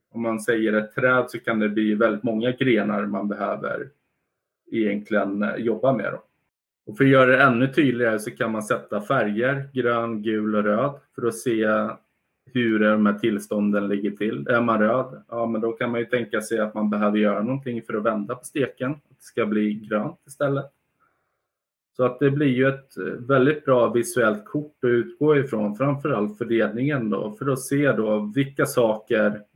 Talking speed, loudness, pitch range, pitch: 185 wpm, -23 LUFS, 105-130 Hz, 115 Hz